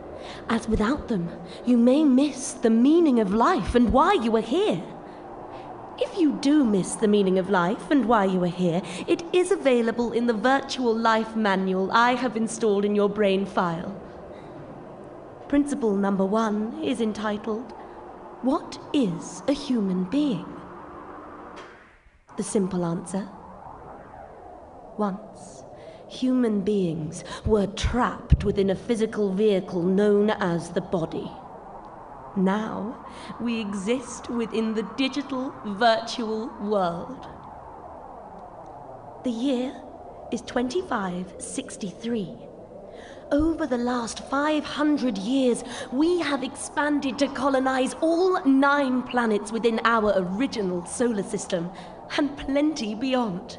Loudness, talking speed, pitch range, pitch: -24 LUFS, 115 wpm, 200-270 Hz, 230 Hz